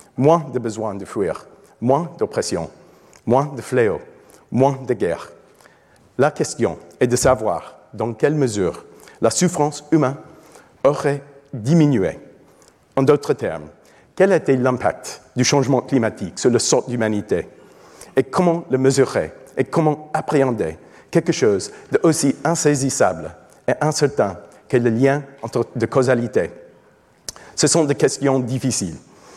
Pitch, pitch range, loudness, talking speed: 135 Hz, 125-155 Hz, -19 LUFS, 125 wpm